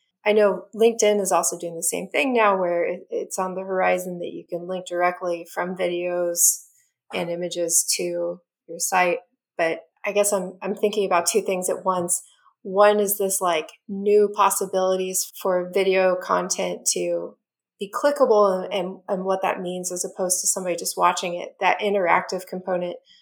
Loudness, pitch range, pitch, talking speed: -22 LUFS, 175-200 Hz, 185 Hz, 170 wpm